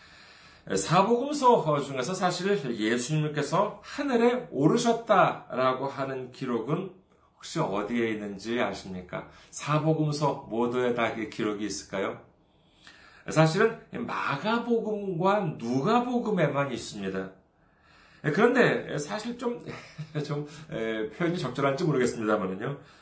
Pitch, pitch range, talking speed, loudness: 150 Hz, 120-200 Hz, 250 characters per minute, -28 LUFS